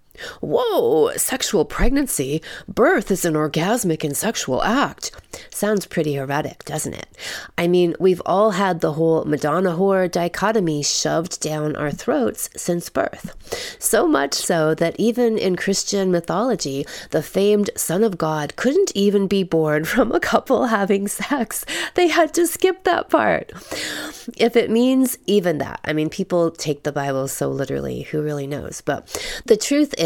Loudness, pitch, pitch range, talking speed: -20 LUFS, 190 Hz, 155-240 Hz, 160 wpm